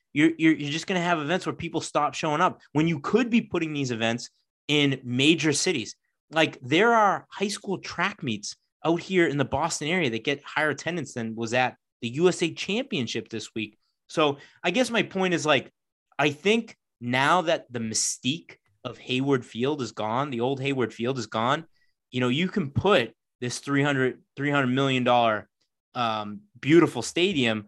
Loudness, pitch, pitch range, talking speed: -25 LUFS, 145 Hz, 120-175 Hz, 185 wpm